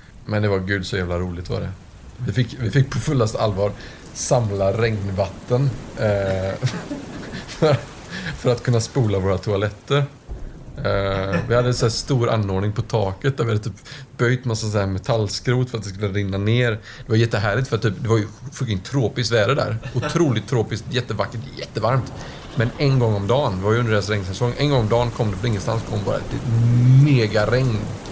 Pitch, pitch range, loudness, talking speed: 115 Hz, 100-125 Hz, -21 LUFS, 190 wpm